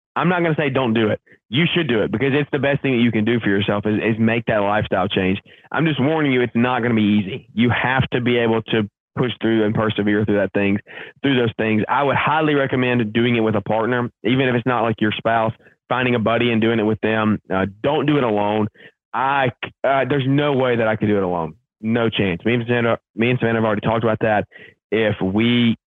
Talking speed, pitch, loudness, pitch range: 255 wpm, 115 Hz, -19 LUFS, 105-125 Hz